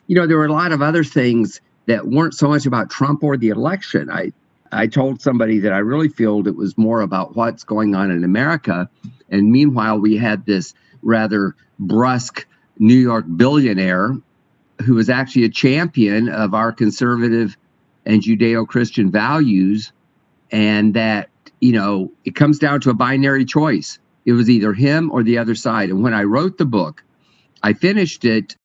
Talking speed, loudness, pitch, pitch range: 180 wpm, -16 LUFS, 115 Hz, 105-135 Hz